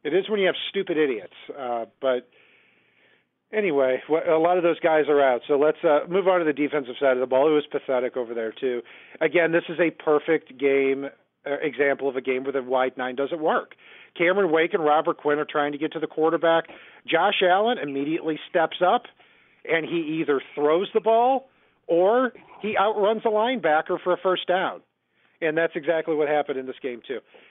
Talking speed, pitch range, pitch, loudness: 205 wpm, 140-180 Hz, 160 Hz, -23 LUFS